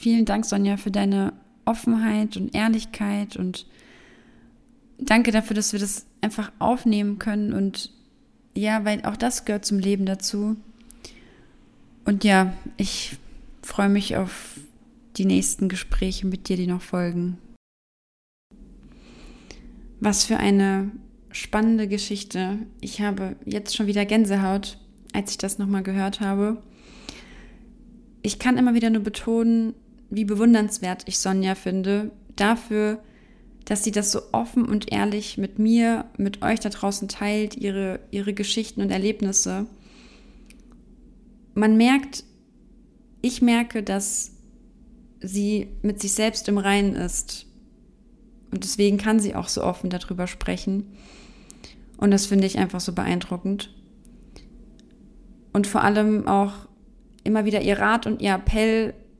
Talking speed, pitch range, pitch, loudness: 130 wpm, 200-230 Hz, 215 Hz, -23 LUFS